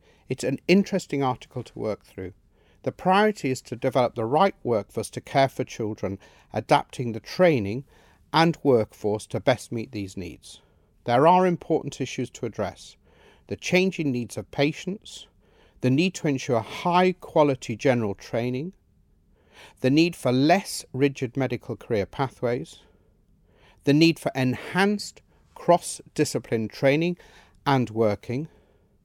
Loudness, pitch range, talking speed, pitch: -25 LUFS, 115-160 Hz, 135 wpm, 130 Hz